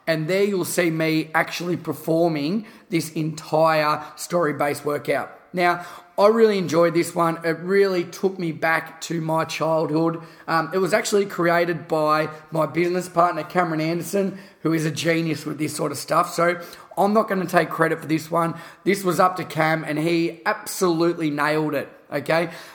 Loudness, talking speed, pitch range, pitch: -22 LUFS, 170 wpm, 160-175 Hz, 165 Hz